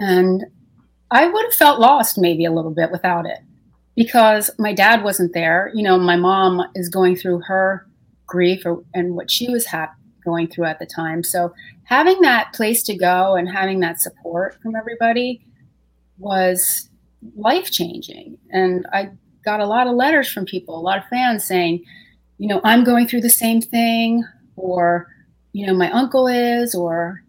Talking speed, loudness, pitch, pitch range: 180 wpm, -17 LUFS, 190 Hz, 180-230 Hz